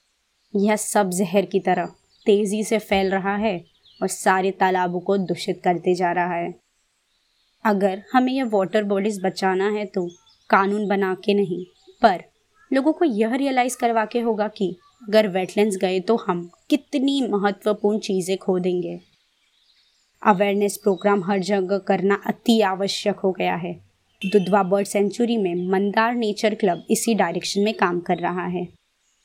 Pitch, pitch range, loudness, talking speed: 200 Hz, 185-215 Hz, -22 LUFS, 150 wpm